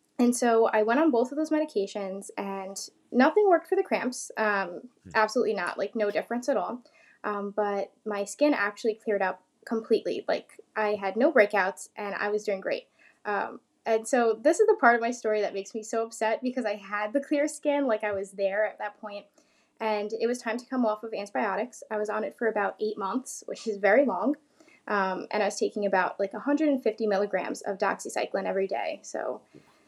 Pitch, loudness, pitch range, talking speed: 220 Hz, -28 LUFS, 205-255 Hz, 210 wpm